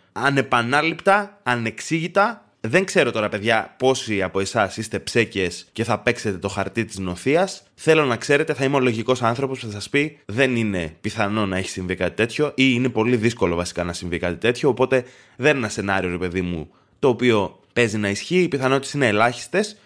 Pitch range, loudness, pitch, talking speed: 100-135 Hz, -21 LUFS, 115 Hz, 195 wpm